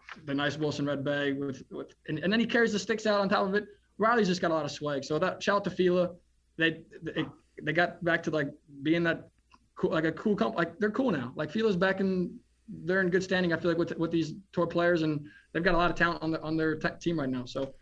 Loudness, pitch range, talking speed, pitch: -29 LUFS, 155-190 Hz, 275 wpm, 170 Hz